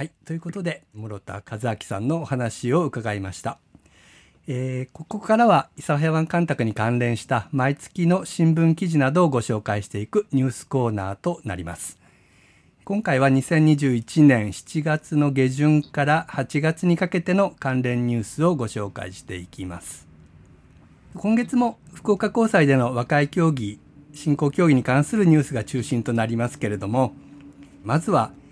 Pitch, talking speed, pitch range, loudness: 140 Hz, 300 characters per minute, 115-160 Hz, -22 LUFS